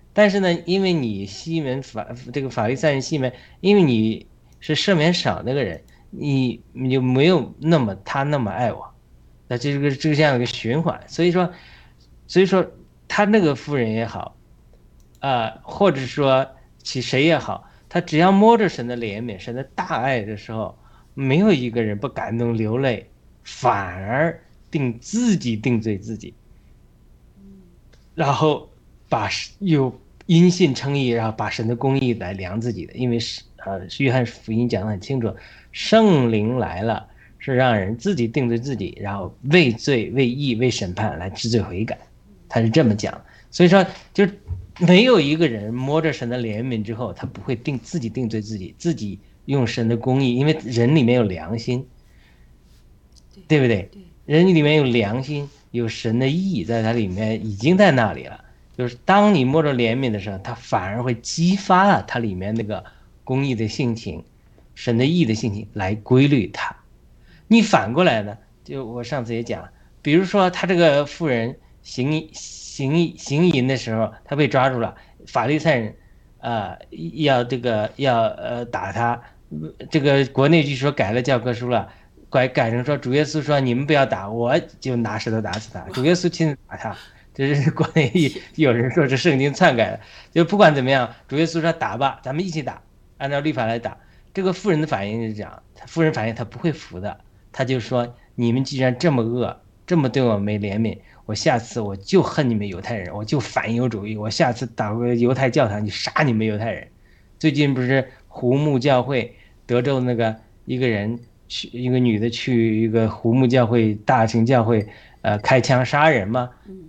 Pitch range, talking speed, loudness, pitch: 110-150 Hz, 260 characters per minute, -20 LUFS, 125 Hz